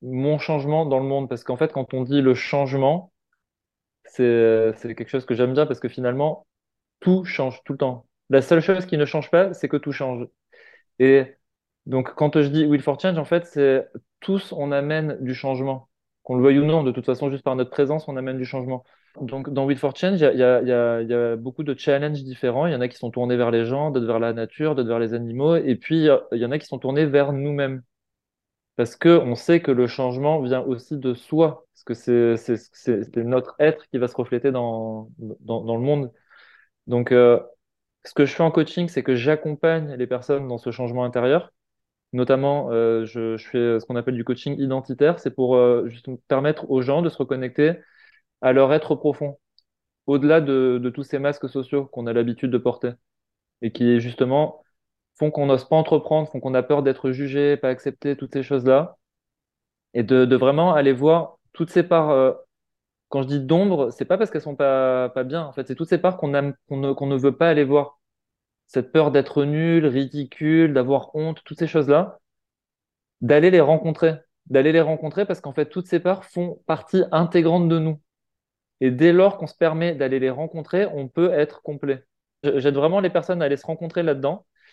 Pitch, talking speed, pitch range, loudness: 140 Hz, 215 wpm, 125-155 Hz, -21 LUFS